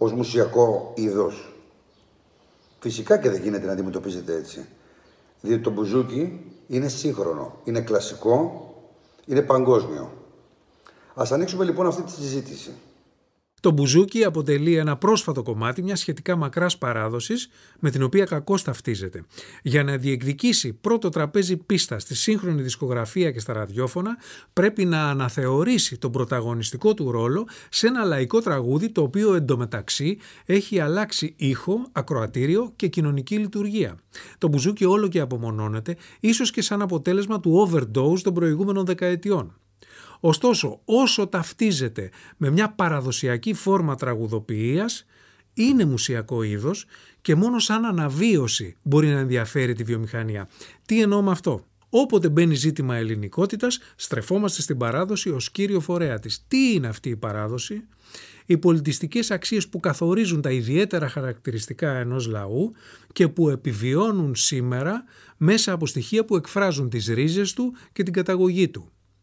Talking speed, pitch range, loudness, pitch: 135 wpm, 125-195 Hz, -23 LUFS, 160 Hz